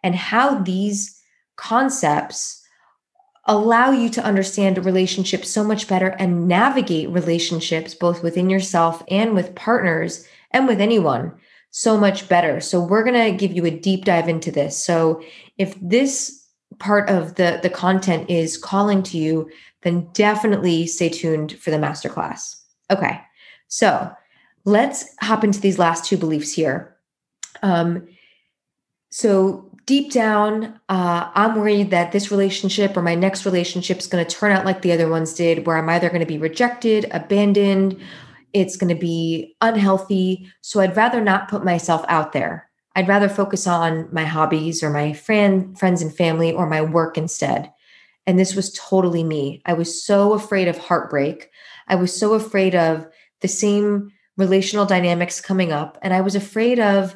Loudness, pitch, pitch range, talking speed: -19 LUFS, 185 Hz, 170-205 Hz, 165 wpm